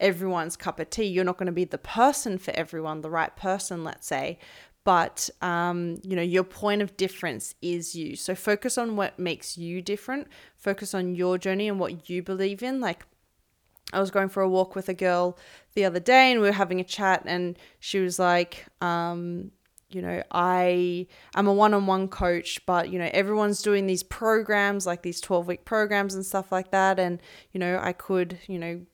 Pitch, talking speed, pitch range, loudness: 185 Hz, 200 wpm, 175-195 Hz, -26 LUFS